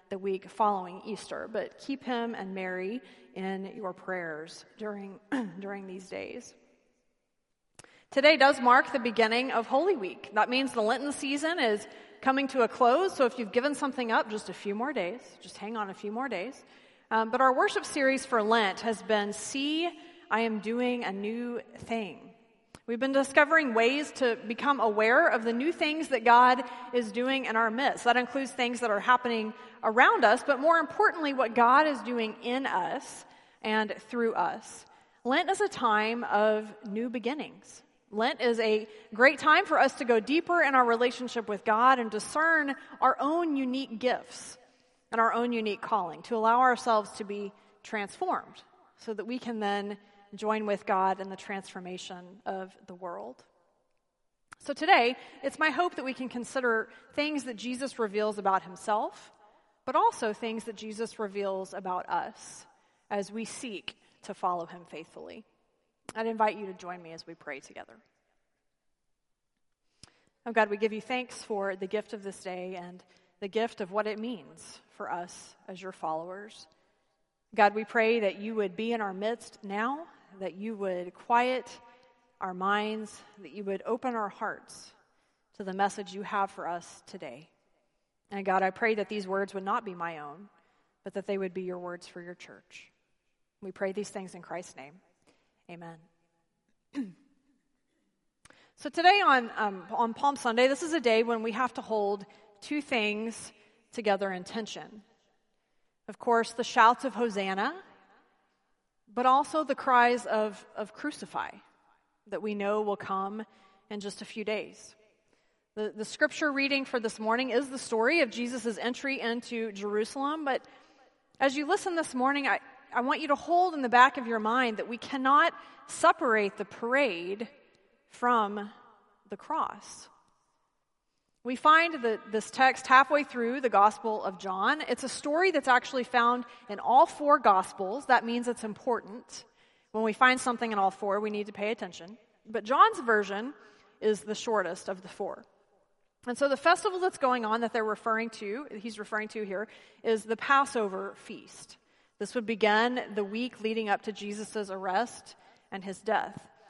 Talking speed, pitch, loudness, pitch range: 170 wpm, 225 Hz, -29 LUFS, 205-255 Hz